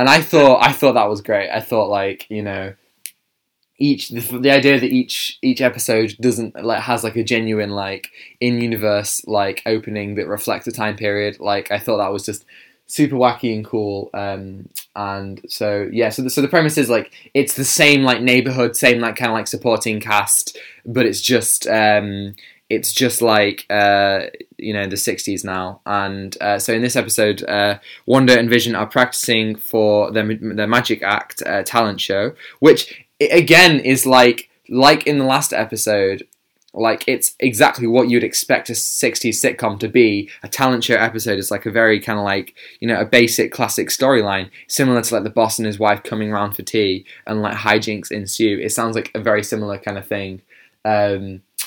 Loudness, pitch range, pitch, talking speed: -16 LUFS, 100-120 Hz, 110 Hz, 195 wpm